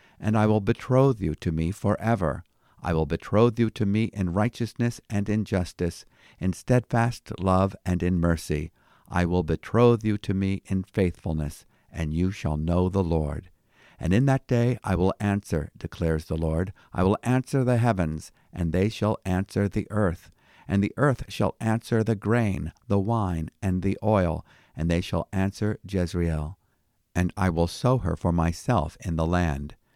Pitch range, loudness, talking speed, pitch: 85-110 Hz, -26 LUFS, 175 wpm, 95 Hz